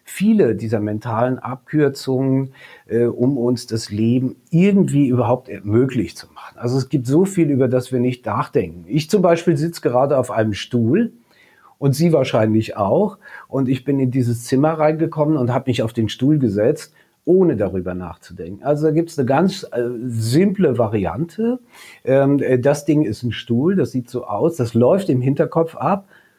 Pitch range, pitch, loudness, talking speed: 120-155 Hz, 130 Hz, -18 LUFS, 175 wpm